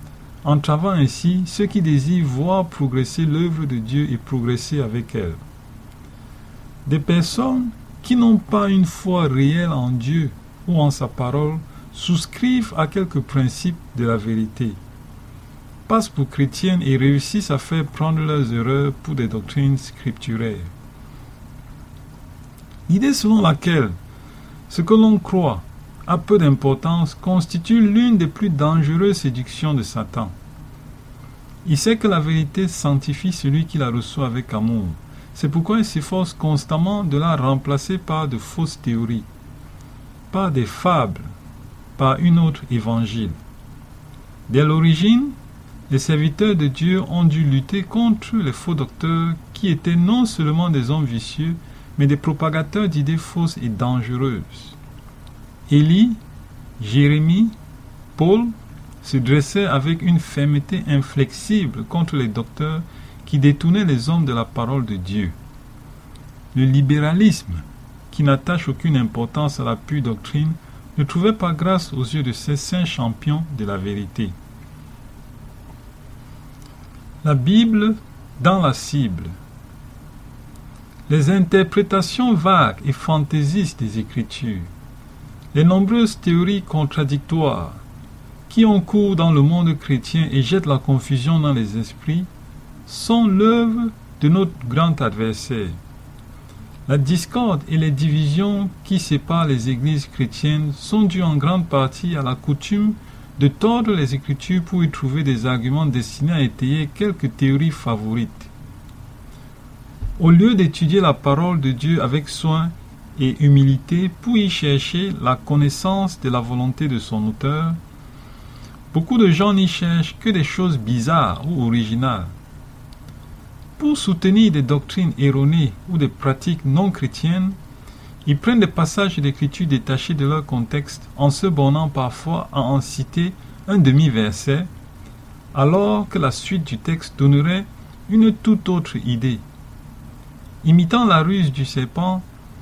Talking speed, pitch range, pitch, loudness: 135 wpm, 130-175 Hz, 150 Hz, -19 LUFS